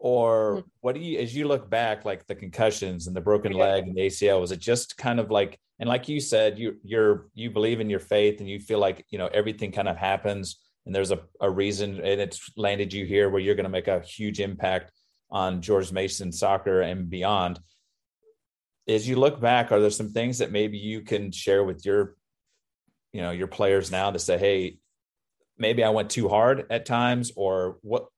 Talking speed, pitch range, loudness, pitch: 215 wpm, 95-115 Hz, -26 LUFS, 100 Hz